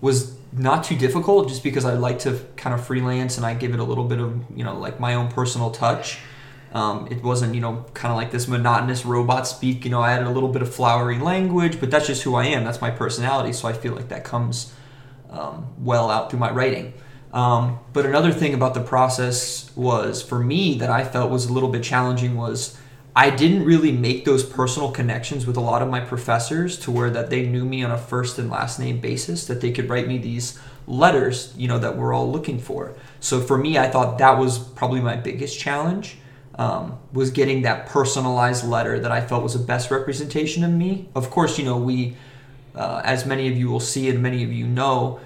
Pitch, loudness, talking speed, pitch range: 125 Hz, -22 LUFS, 230 wpm, 120-135 Hz